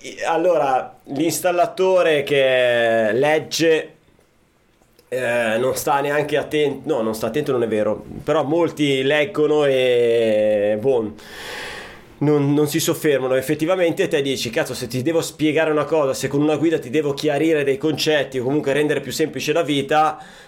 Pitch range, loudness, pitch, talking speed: 130-155 Hz, -19 LUFS, 150 Hz, 150 wpm